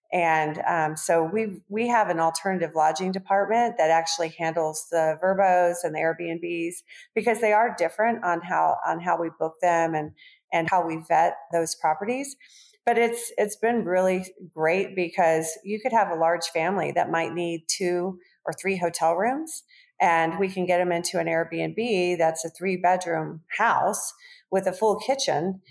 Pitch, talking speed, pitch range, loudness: 180 Hz, 175 wpm, 165-210 Hz, -24 LUFS